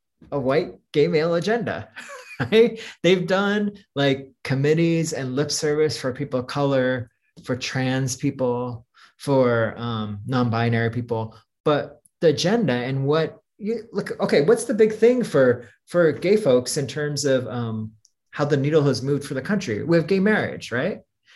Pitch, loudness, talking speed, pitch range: 145 Hz, -22 LUFS, 160 wpm, 125-170 Hz